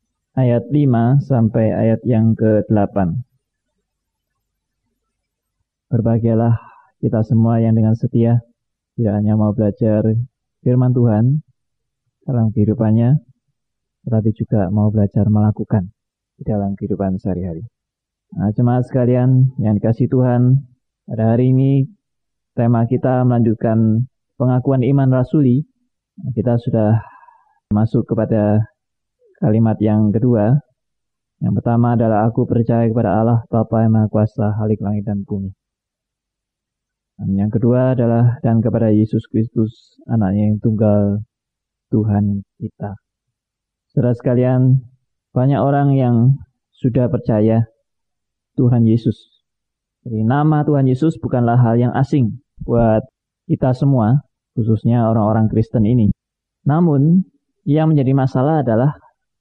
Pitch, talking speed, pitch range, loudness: 115 Hz, 110 wpm, 110-130 Hz, -16 LUFS